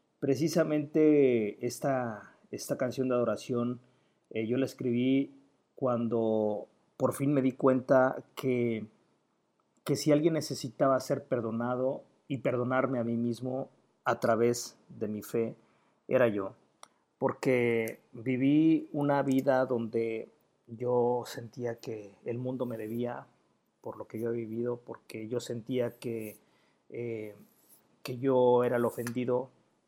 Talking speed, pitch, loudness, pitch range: 125 wpm, 125 Hz, -31 LUFS, 115-135 Hz